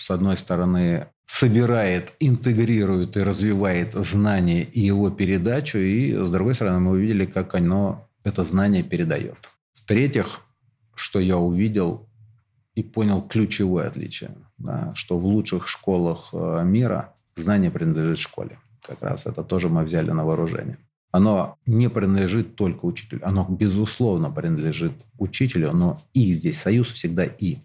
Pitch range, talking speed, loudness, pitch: 95-120 Hz, 135 wpm, -22 LUFS, 100 Hz